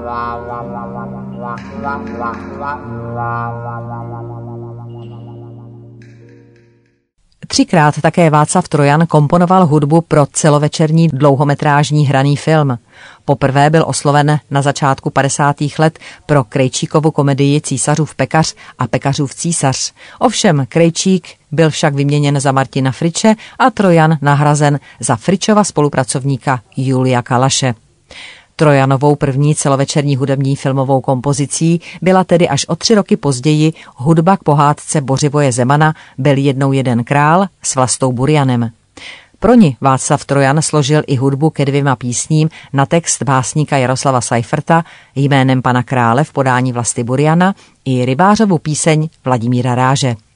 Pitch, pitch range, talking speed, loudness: 140 Hz, 130-155 Hz, 110 wpm, -13 LUFS